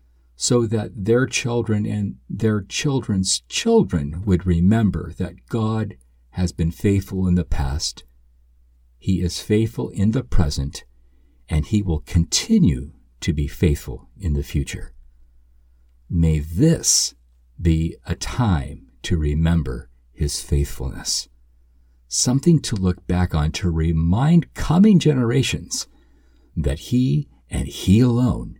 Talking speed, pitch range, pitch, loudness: 120 wpm, 65-105 Hz, 85 Hz, -21 LUFS